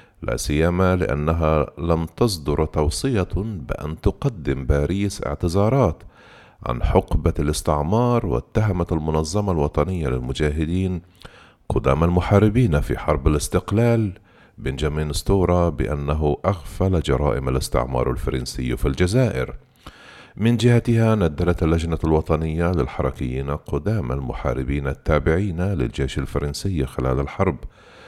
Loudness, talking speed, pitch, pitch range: -22 LUFS, 95 wpm, 80 Hz, 70-95 Hz